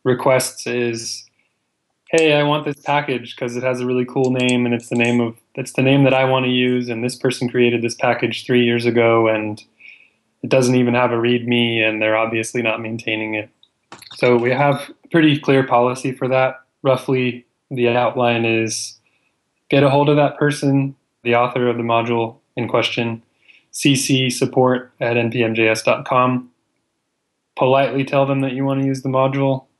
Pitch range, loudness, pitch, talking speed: 120-135 Hz, -18 LUFS, 125 Hz, 175 wpm